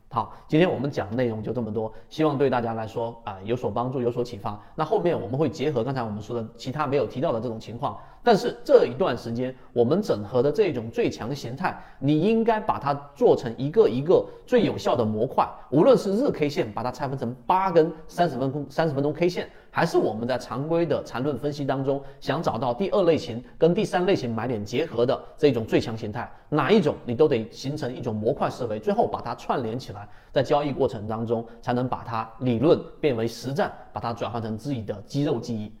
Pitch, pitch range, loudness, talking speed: 125 Hz, 115-150 Hz, -25 LUFS, 335 characters per minute